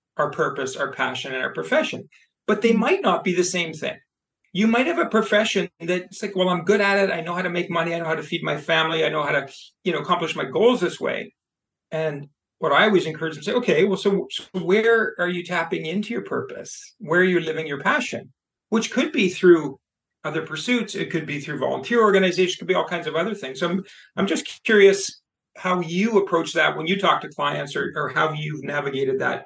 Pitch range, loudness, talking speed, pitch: 165-200 Hz, -22 LUFS, 230 wpm, 180 Hz